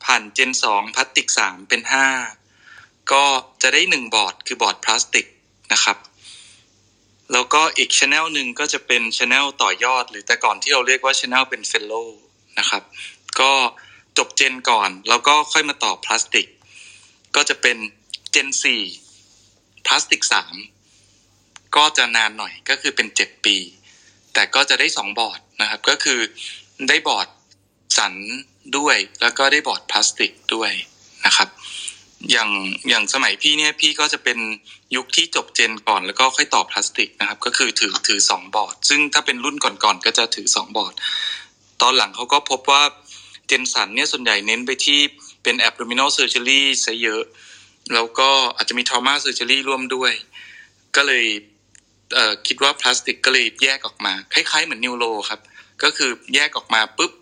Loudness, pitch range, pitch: -17 LUFS, 105-140 Hz, 125 Hz